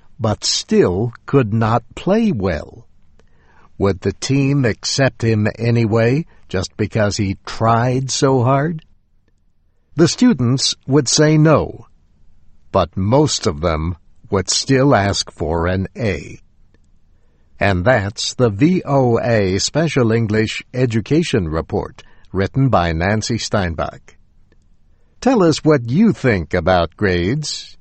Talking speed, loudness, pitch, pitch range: 110 wpm, -17 LUFS, 110 Hz, 90-135 Hz